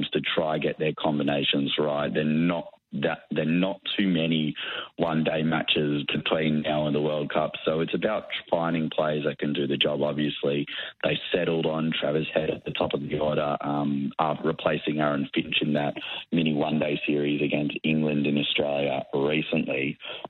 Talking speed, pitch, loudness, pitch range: 175 wpm, 75 Hz, -26 LUFS, 75-80 Hz